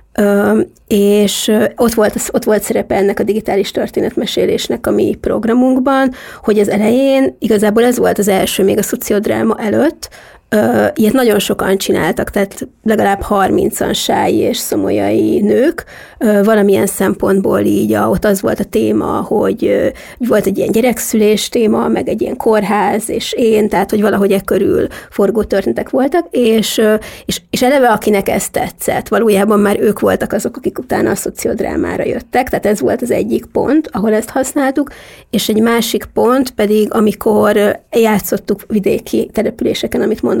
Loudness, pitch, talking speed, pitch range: -13 LUFS, 215 Hz, 155 wpm, 205-235 Hz